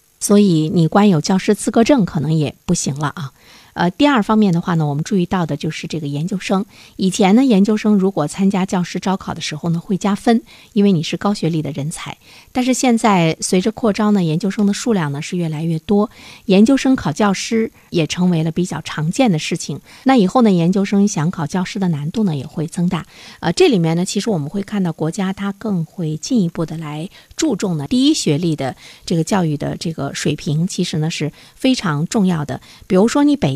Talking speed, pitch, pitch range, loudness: 320 characters per minute, 185 Hz, 160-205 Hz, -17 LUFS